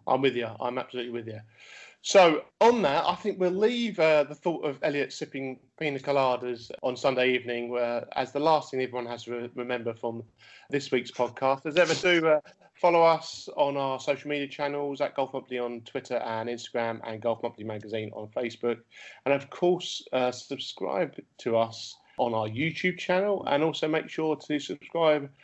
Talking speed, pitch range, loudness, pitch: 190 wpm, 120-155 Hz, -28 LUFS, 135 Hz